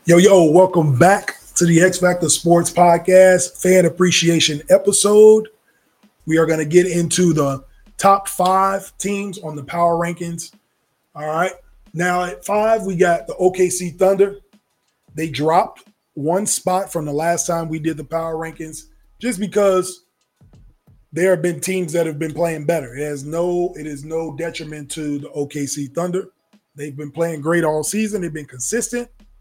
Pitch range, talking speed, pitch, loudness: 160-190 Hz, 165 wpm, 175 Hz, -17 LUFS